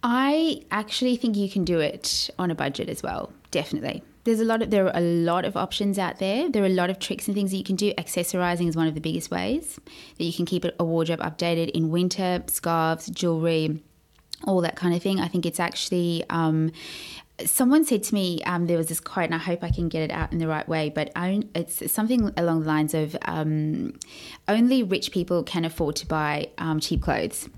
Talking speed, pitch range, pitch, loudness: 230 wpm, 165-205 Hz, 175 Hz, -25 LUFS